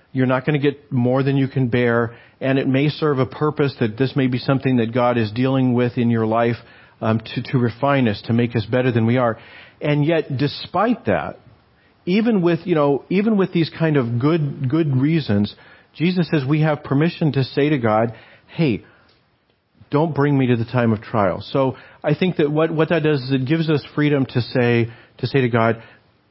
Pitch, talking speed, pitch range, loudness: 135 Hz, 220 wpm, 120-150 Hz, -19 LUFS